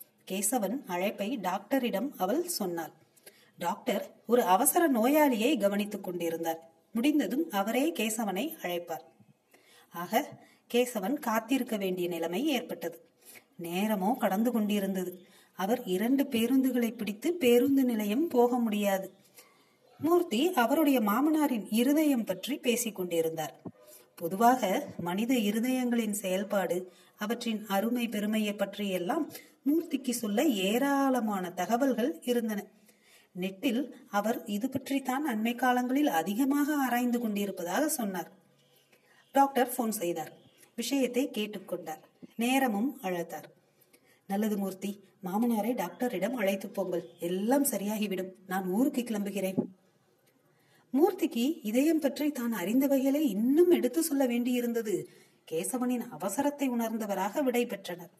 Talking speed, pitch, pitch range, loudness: 90 wpm, 230 Hz, 195-260 Hz, -30 LUFS